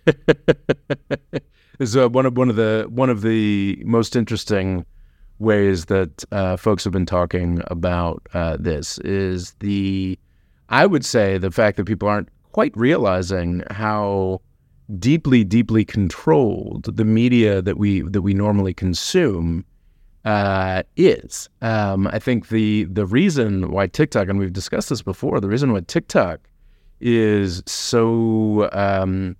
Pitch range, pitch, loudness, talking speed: 95-115 Hz, 100 Hz, -19 LUFS, 140 wpm